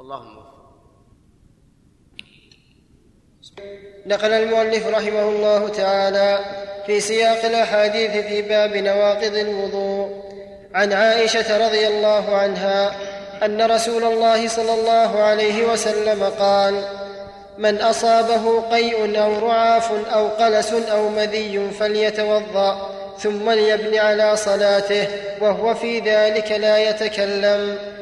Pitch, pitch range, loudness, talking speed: 210 Hz, 200-220 Hz, -18 LUFS, 95 wpm